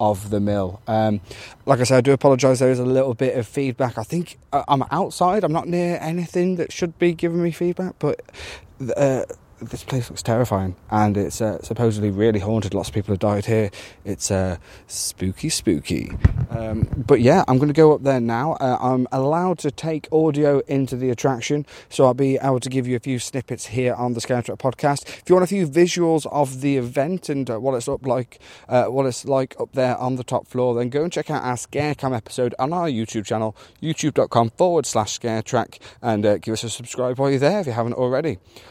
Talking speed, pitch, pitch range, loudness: 225 wpm, 130 Hz, 115-145 Hz, -21 LUFS